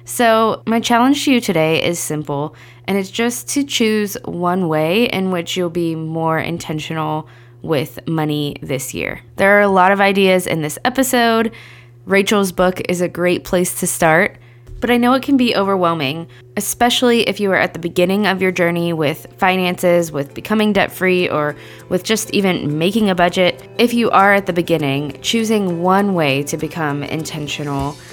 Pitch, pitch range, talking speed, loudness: 180 Hz, 155-205 Hz, 180 wpm, -16 LUFS